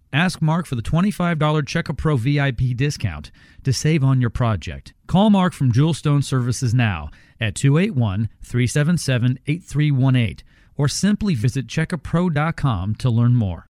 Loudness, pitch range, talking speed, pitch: -20 LUFS, 120-160 Hz, 125 wpm, 135 Hz